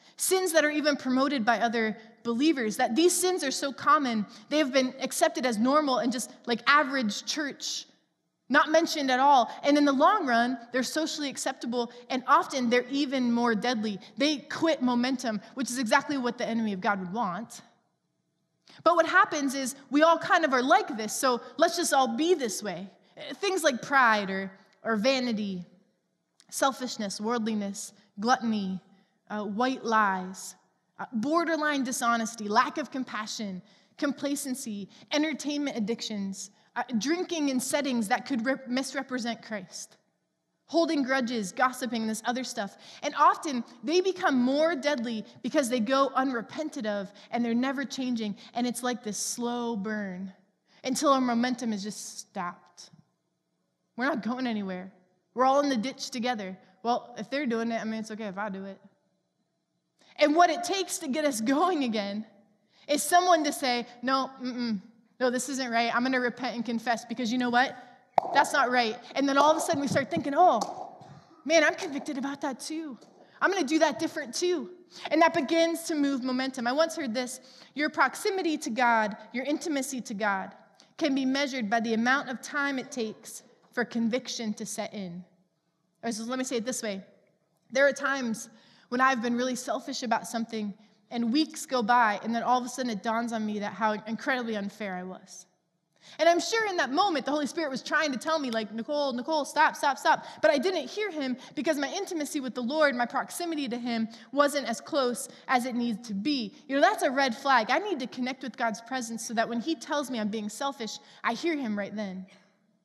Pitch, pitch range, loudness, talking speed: 250 Hz, 220-290 Hz, -28 LUFS, 190 wpm